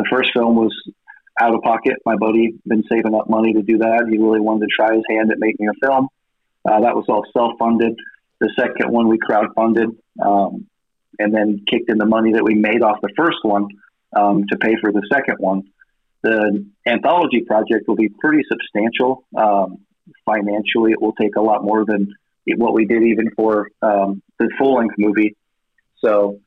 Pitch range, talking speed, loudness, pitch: 105-115 Hz, 195 wpm, -17 LUFS, 110 Hz